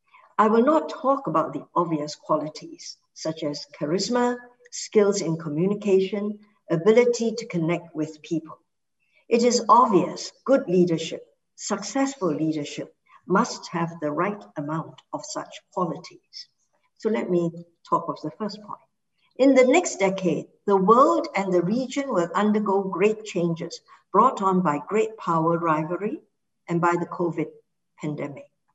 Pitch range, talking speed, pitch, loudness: 165-235 Hz, 140 wpm, 195 Hz, -24 LUFS